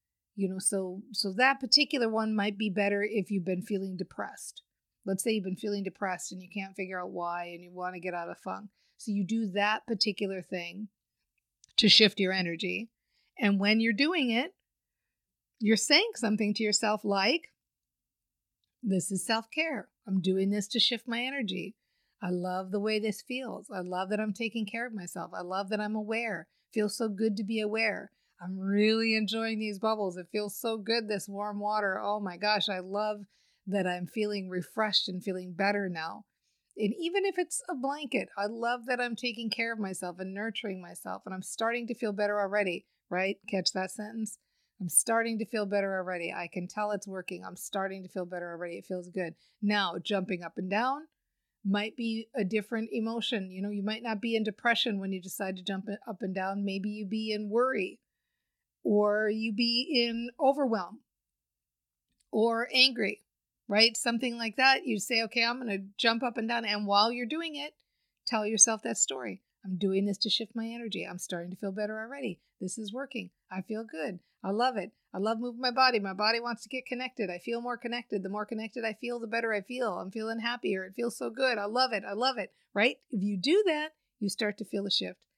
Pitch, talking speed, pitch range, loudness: 210 Hz, 205 wpm, 195-230 Hz, -30 LUFS